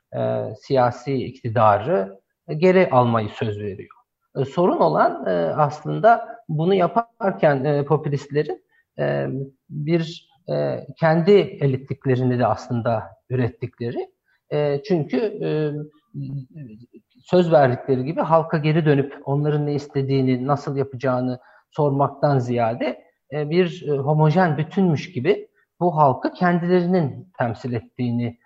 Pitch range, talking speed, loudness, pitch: 125-170 Hz, 110 wpm, -21 LUFS, 145 Hz